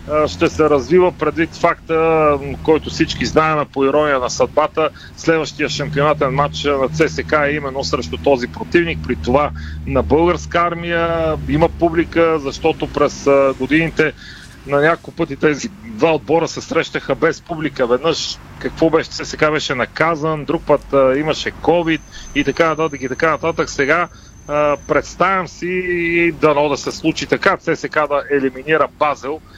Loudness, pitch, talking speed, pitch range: -17 LUFS, 155 Hz, 140 wpm, 145-165 Hz